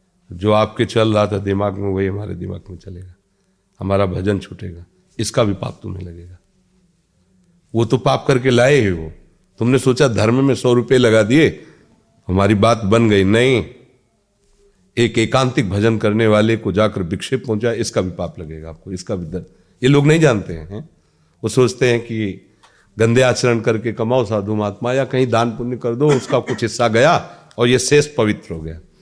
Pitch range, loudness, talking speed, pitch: 95-125 Hz, -16 LUFS, 185 wpm, 110 Hz